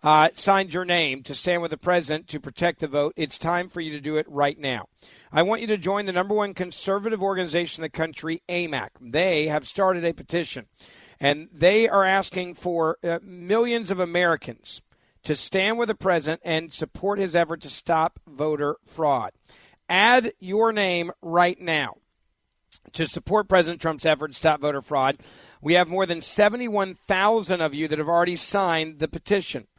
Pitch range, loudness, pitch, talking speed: 155-190 Hz, -23 LUFS, 170 Hz, 180 wpm